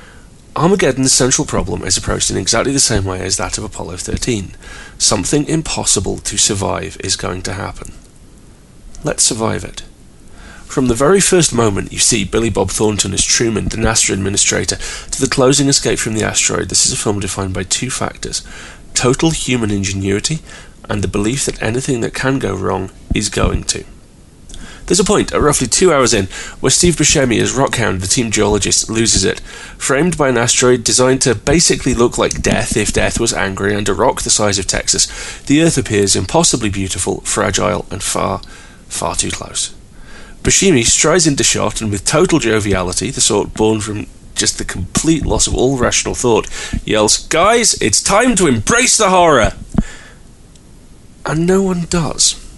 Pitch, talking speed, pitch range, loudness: 110 Hz, 175 wpm, 100-135 Hz, -14 LUFS